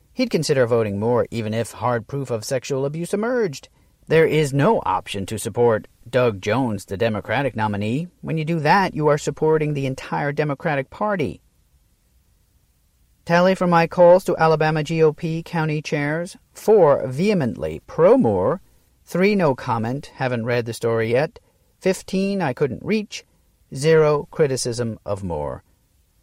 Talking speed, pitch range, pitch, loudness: 145 wpm, 115-165 Hz, 140 Hz, -20 LUFS